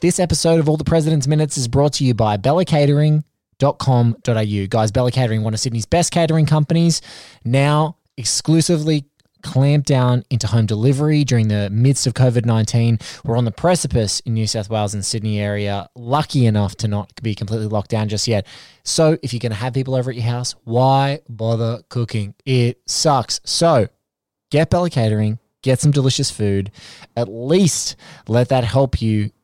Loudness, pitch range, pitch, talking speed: -18 LUFS, 110-145 Hz, 125 Hz, 175 wpm